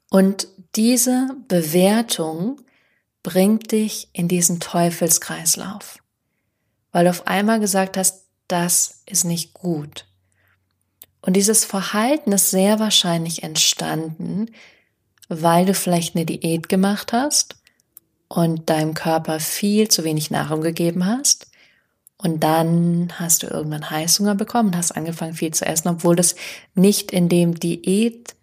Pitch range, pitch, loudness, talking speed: 165-205 Hz, 180 Hz, -19 LUFS, 125 wpm